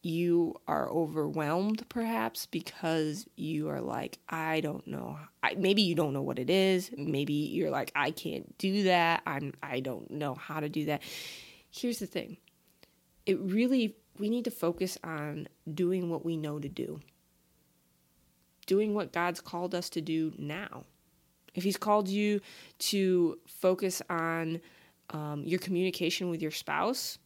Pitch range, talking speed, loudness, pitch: 150-190 Hz, 155 wpm, -32 LUFS, 170 Hz